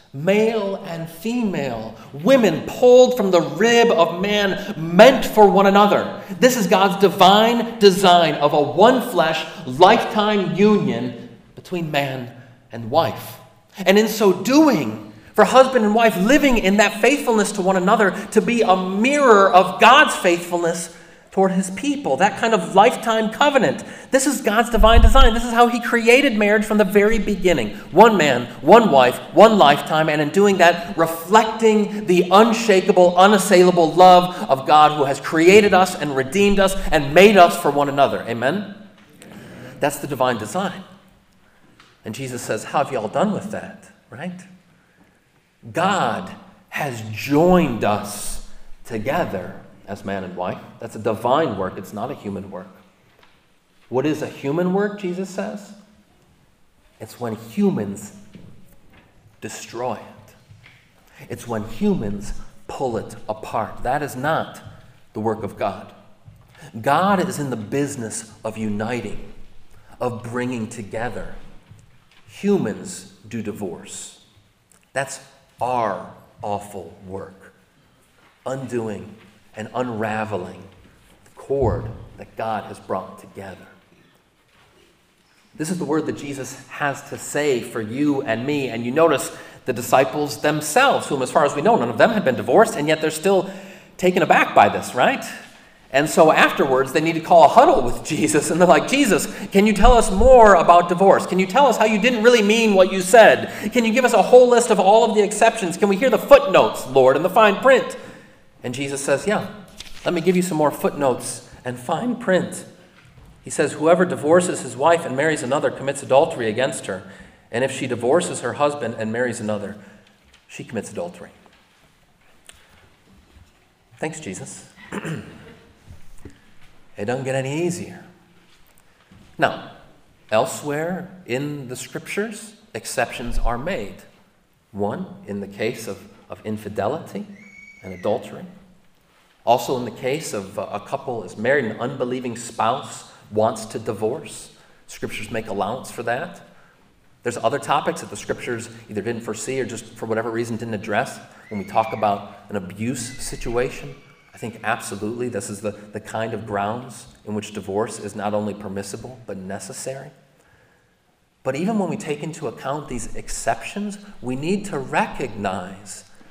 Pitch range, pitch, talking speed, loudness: 120-200 Hz, 165 Hz, 155 wpm, -18 LUFS